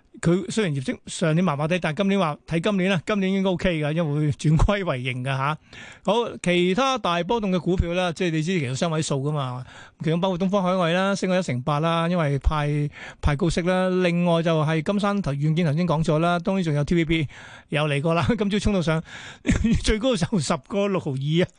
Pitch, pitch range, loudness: 175 Hz, 150-190 Hz, -23 LUFS